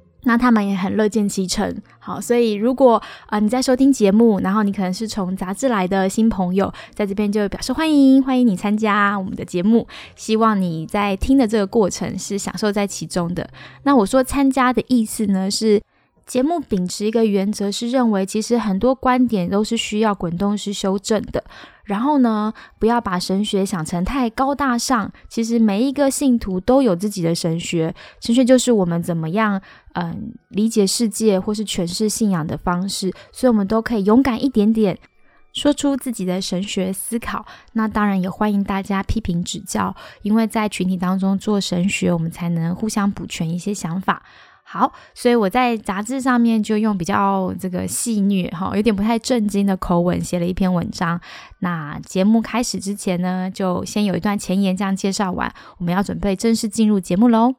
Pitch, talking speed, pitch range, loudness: 205 Hz, 290 characters per minute, 190-230 Hz, -19 LUFS